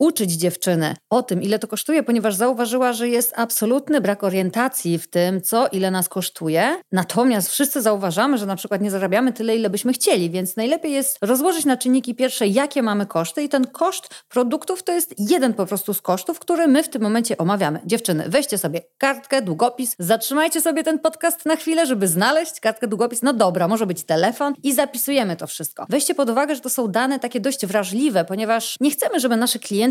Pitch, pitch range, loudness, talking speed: 240 Hz, 200-275 Hz, -20 LUFS, 200 wpm